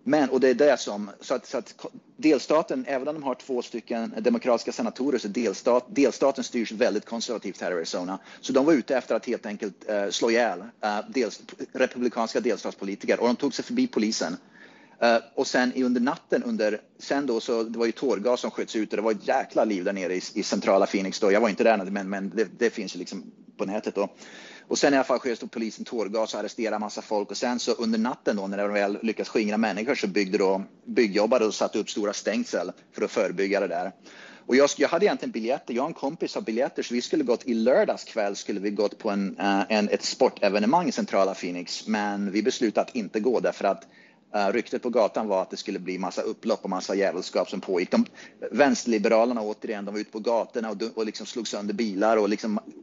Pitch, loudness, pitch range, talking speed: 110 Hz, -26 LUFS, 100-125 Hz, 230 wpm